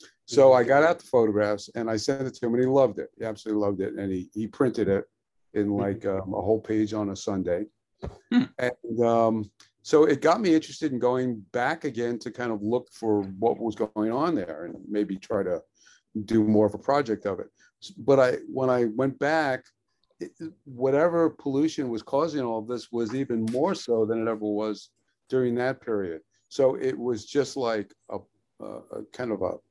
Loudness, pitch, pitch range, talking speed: -26 LUFS, 115 Hz, 105-135 Hz, 205 wpm